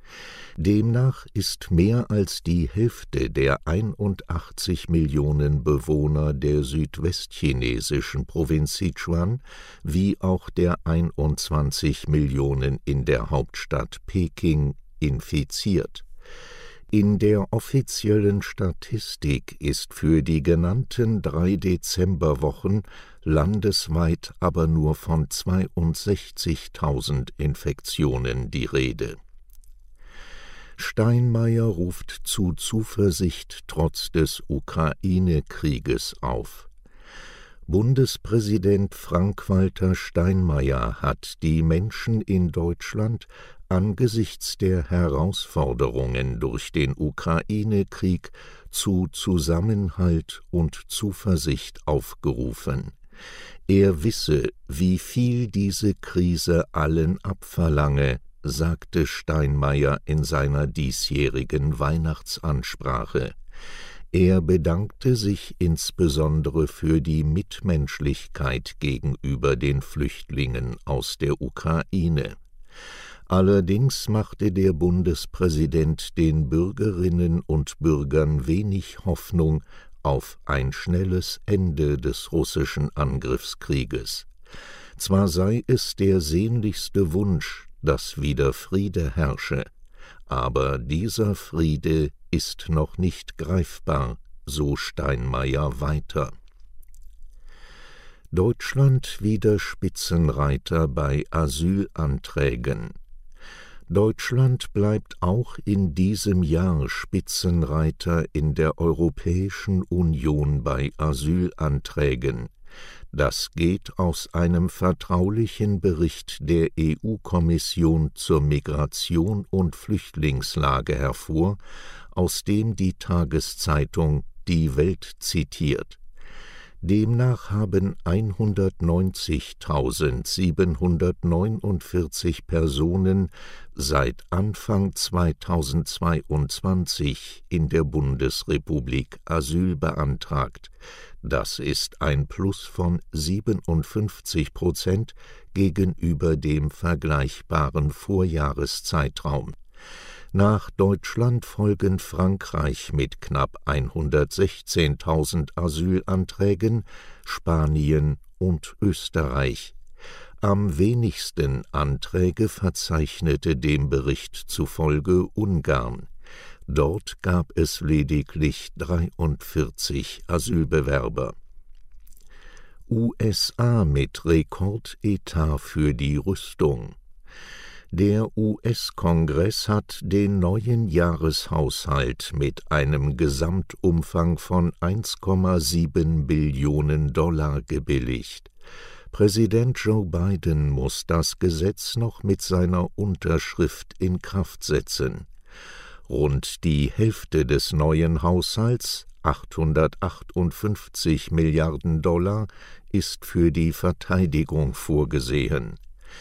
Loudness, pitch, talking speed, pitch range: -24 LUFS, 85 Hz, 75 wpm, 75-95 Hz